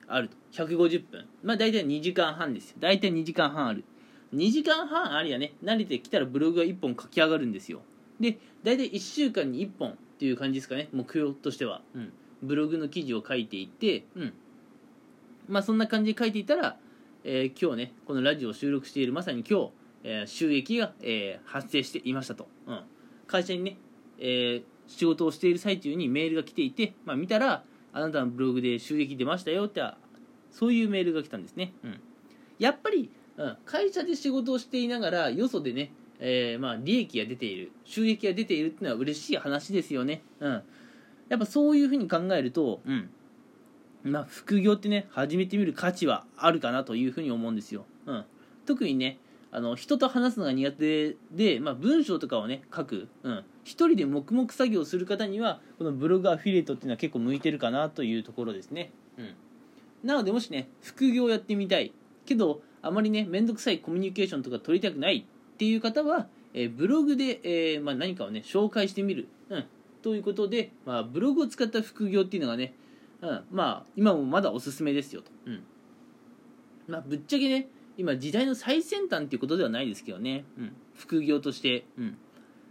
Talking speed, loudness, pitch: 390 characters per minute, -29 LUFS, 210 Hz